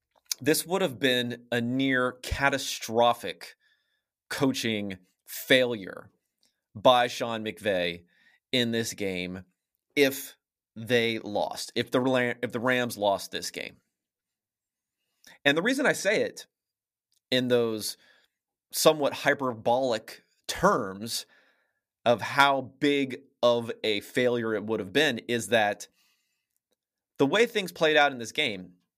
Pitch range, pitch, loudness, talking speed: 110-135 Hz, 120 Hz, -27 LUFS, 115 wpm